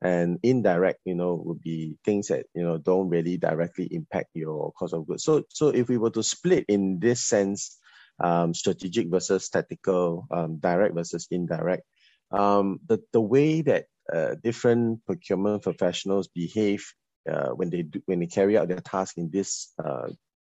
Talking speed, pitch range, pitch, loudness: 175 wpm, 85-100 Hz, 95 Hz, -26 LUFS